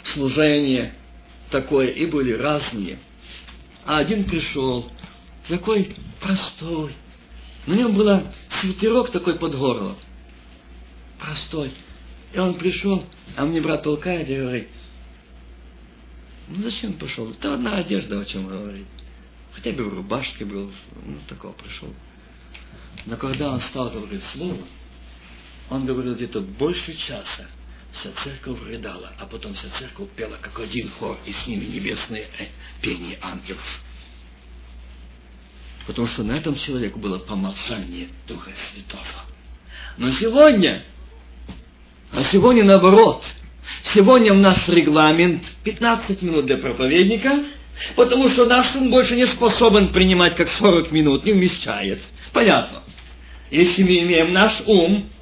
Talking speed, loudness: 125 wpm, -19 LUFS